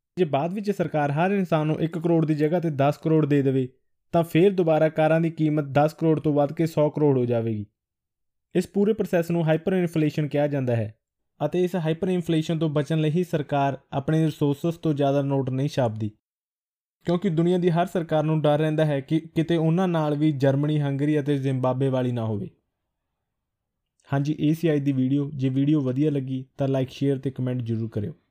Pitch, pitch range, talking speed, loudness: 150 Hz, 135-165 Hz, 195 wpm, -24 LUFS